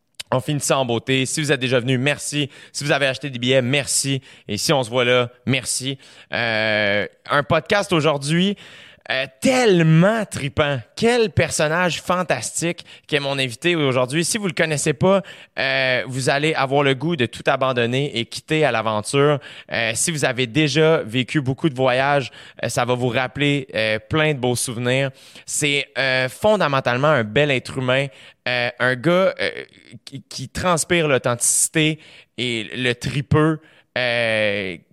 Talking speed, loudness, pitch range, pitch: 165 wpm, -19 LUFS, 125-155 Hz, 135 Hz